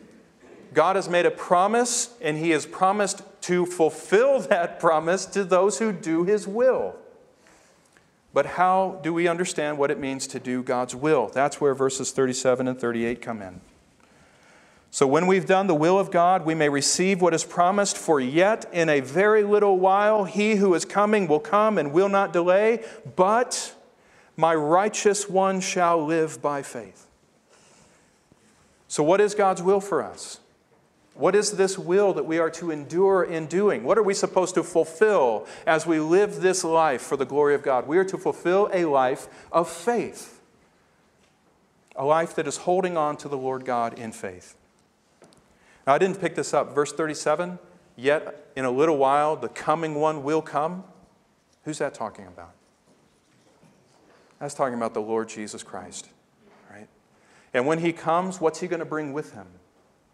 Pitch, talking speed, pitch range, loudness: 170 Hz, 175 wpm, 150-190 Hz, -23 LUFS